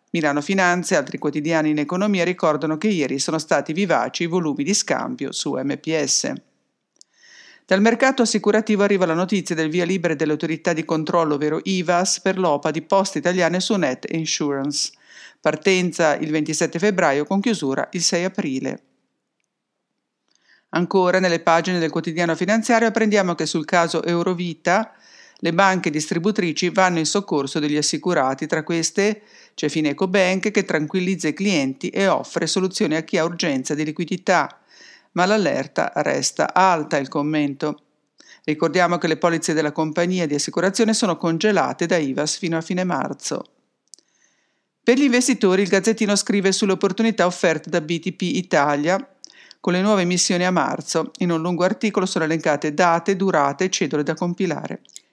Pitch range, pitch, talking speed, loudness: 160-195 Hz, 175 Hz, 150 wpm, -20 LUFS